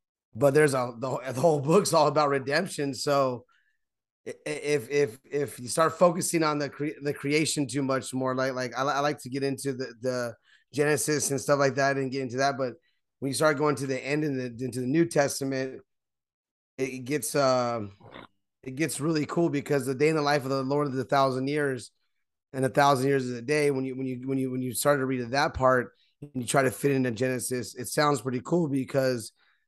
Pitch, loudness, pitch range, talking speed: 135 Hz, -27 LUFS, 130-145 Hz, 220 wpm